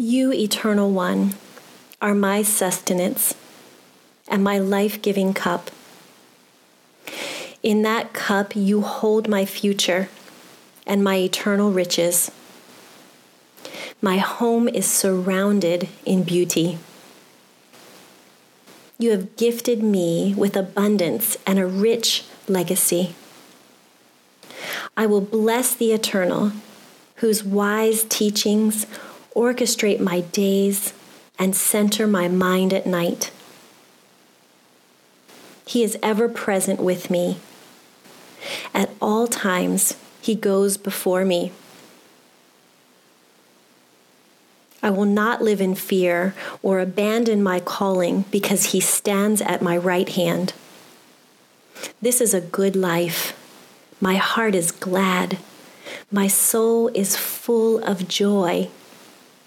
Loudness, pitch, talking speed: -20 LUFS, 185 Hz, 100 wpm